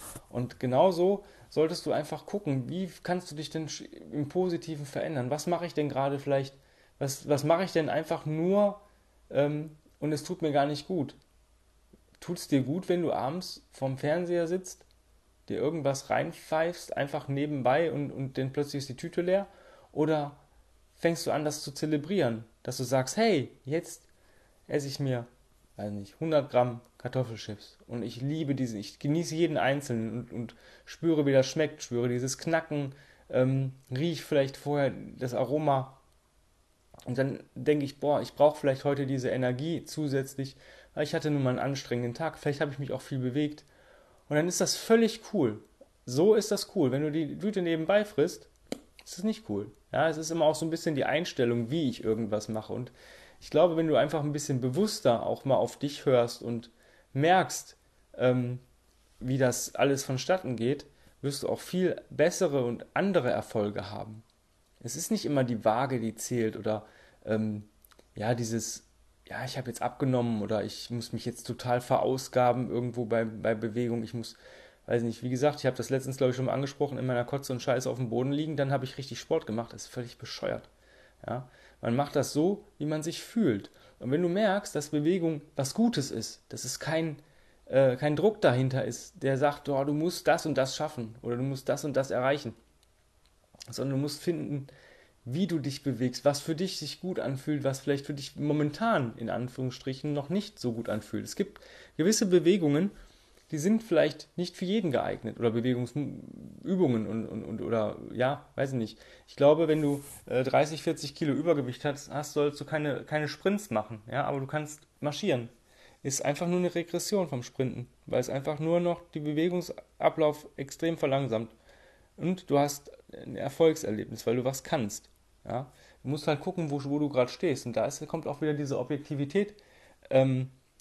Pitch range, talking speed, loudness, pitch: 125-155 Hz, 185 wpm, -30 LUFS, 140 Hz